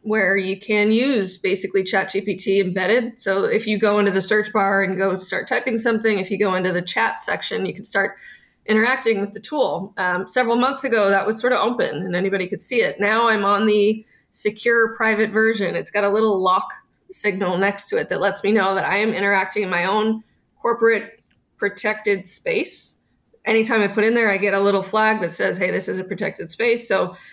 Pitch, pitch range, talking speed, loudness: 205 Hz, 195-225 Hz, 215 wpm, -20 LUFS